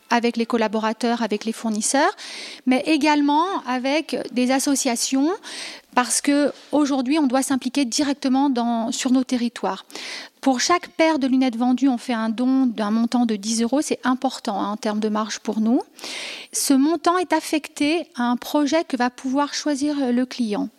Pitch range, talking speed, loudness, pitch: 240-295 Hz, 165 wpm, -21 LUFS, 265 Hz